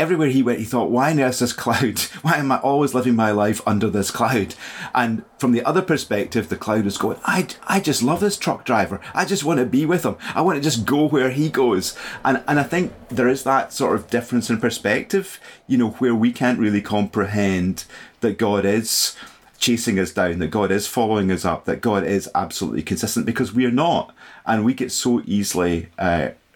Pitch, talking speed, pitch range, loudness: 120 Hz, 215 wpm, 105-135 Hz, -20 LUFS